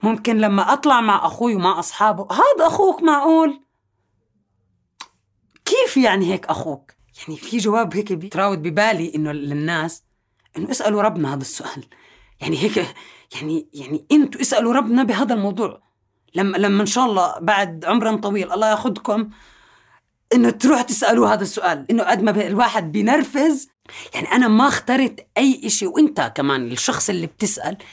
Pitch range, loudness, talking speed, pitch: 160-250 Hz, -18 LUFS, 145 wpm, 210 Hz